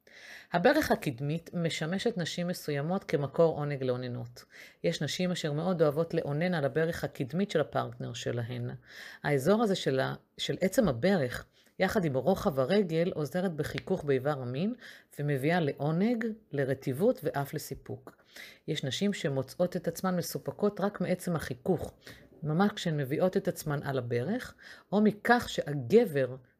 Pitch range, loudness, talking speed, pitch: 140-190 Hz, -31 LUFS, 130 wpm, 165 Hz